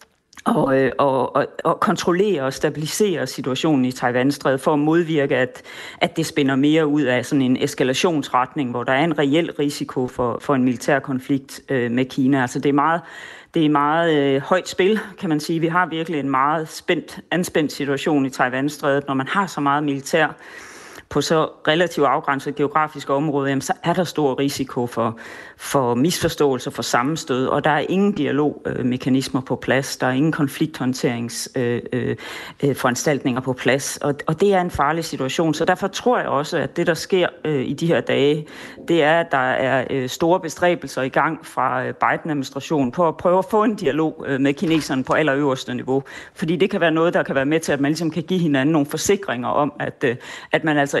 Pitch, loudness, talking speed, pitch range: 145 Hz, -20 LUFS, 185 wpm, 135-165 Hz